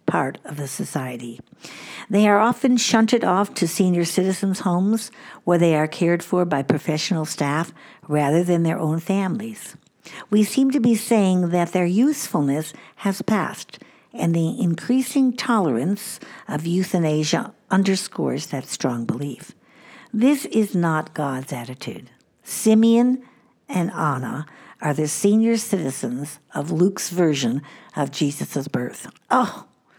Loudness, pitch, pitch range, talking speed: -21 LUFS, 180 Hz, 155-220 Hz, 130 wpm